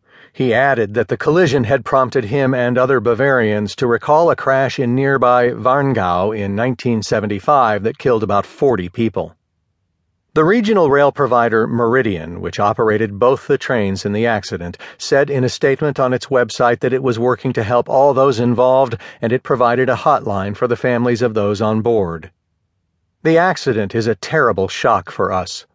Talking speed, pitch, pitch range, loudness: 170 wpm, 120 Hz, 105-135 Hz, -15 LUFS